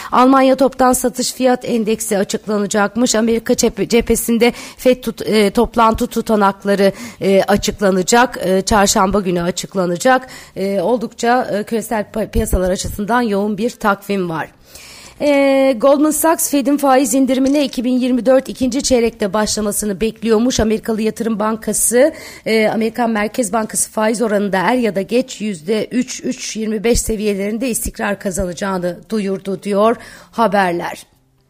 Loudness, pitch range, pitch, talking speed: -16 LUFS, 200-250 Hz, 220 Hz, 120 wpm